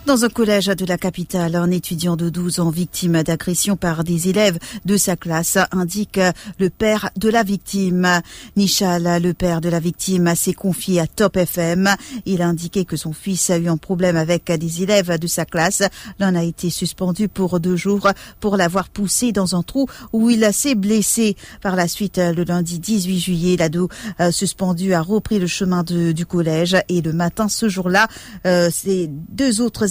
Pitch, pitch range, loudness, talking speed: 185 Hz, 175-200 Hz, -18 LUFS, 190 wpm